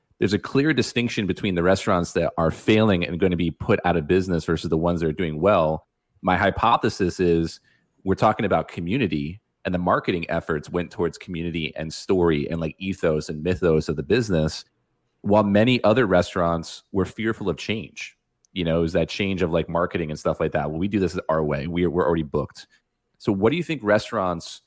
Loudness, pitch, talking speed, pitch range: -23 LUFS, 85 Hz, 210 wpm, 80-95 Hz